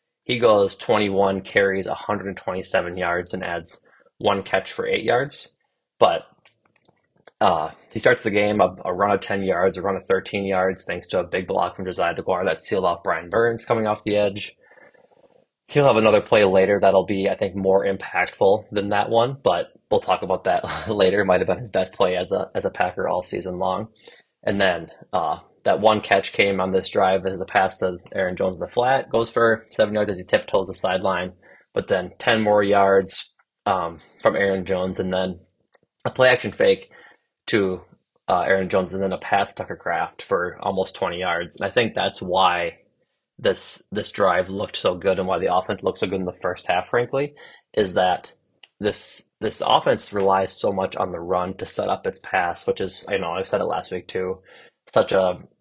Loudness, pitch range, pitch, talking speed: -22 LUFS, 95-115 Hz, 100 Hz, 205 wpm